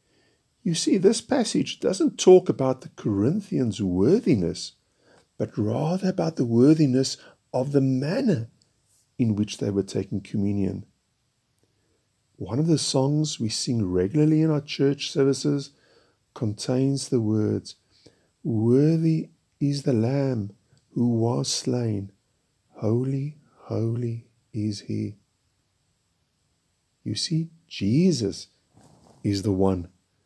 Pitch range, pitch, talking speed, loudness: 105-145 Hz, 120 Hz, 110 wpm, -24 LUFS